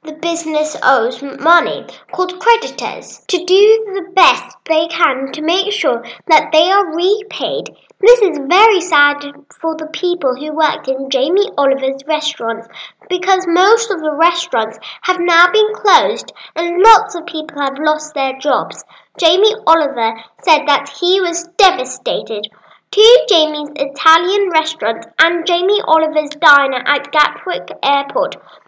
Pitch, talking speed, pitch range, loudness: 320 Hz, 140 wpm, 285-370 Hz, -13 LUFS